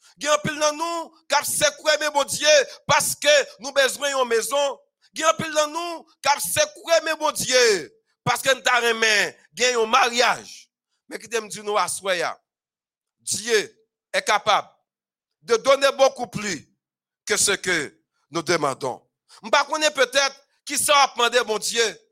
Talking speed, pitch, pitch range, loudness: 170 wpm, 275 Hz, 230-305 Hz, -21 LUFS